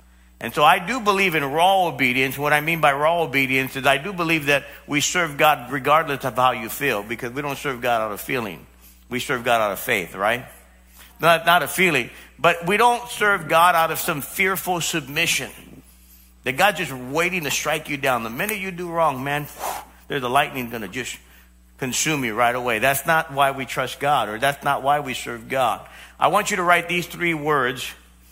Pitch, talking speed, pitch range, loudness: 145 Hz, 215 wpm, 125-170 Hz, -21 LUFS